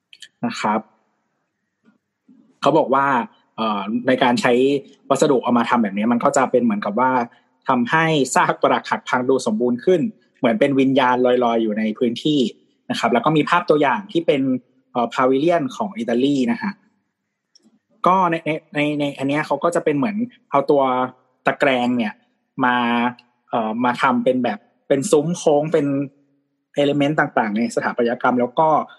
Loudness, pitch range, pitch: -19 LUFS, 125-160 Hz, 135 Hz